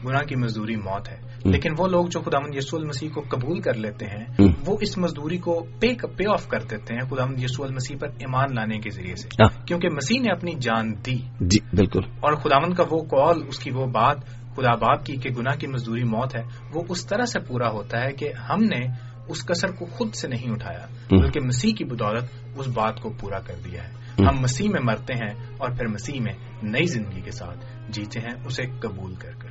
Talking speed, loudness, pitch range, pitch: 235 wpm, -24 LUFS, 115-140 Hz, 125 Hz